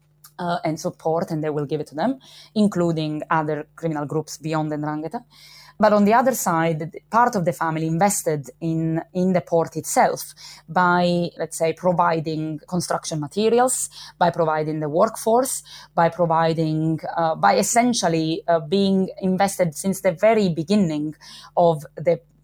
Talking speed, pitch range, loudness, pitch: 150 wpm, 160-185 Hz, -21 LUFS, 165 Hz